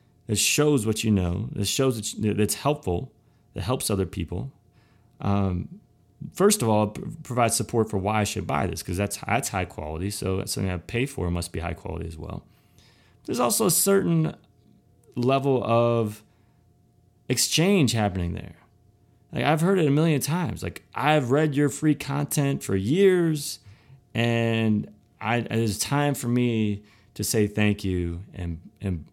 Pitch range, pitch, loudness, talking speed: 100-135 Hz, 115 Hz, -25 LUFS, 170 wpm